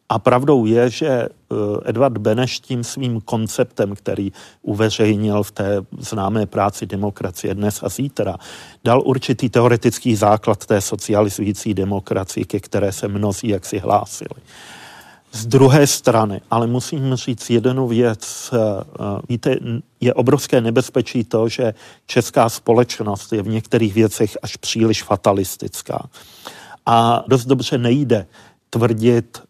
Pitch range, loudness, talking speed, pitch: 105-125 Hz, -18 LUFS, 125 wpm, 115 Hz